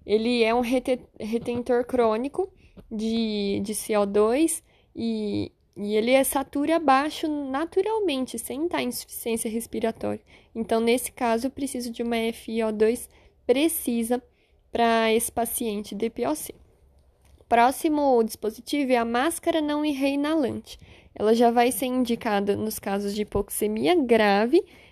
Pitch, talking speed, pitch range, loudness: 235 Hz, 120 wpm, 220-270 Hz, -25 LUFS